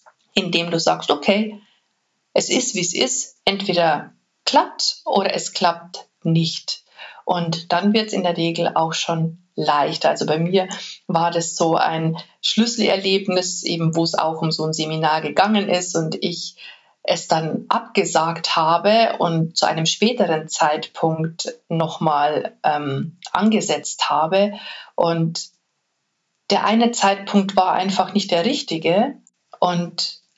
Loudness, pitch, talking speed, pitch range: -20 LUFS, 170 Hz, 135 wpm, 165-195 Hz